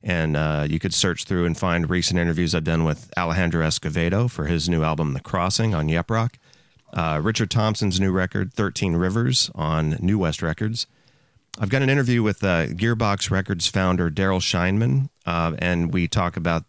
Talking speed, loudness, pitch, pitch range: 185 wpm, -22 LUFS, 90 Hz, 85-110 Hz